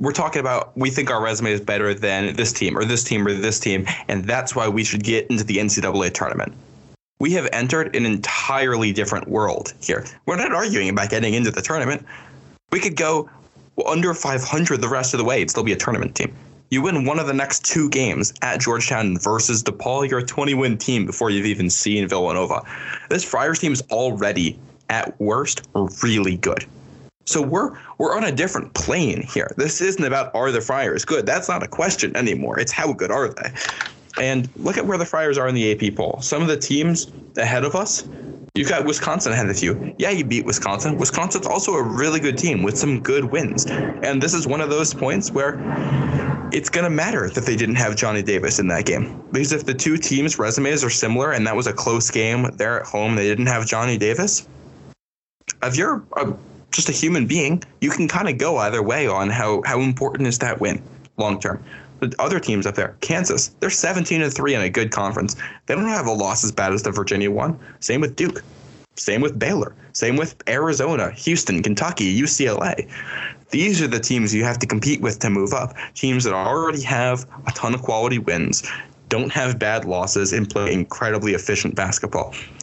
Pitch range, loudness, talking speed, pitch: 105-140 Hz, -20 LUFS, 210 wpm, 125 Hz